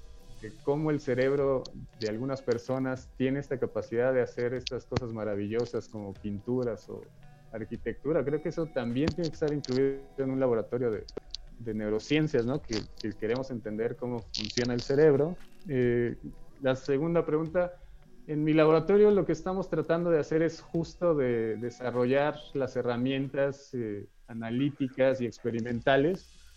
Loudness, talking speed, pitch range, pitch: -30 LUFS, 145 wpm, 120-150 Hz, 130 Hz